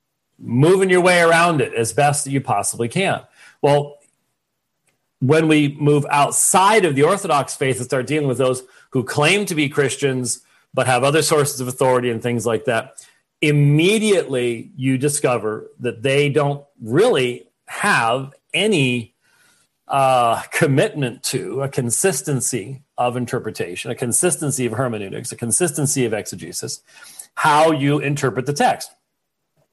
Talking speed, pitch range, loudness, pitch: 140 wpm, 125-150 Hz, -18 LUFS, 140 Hz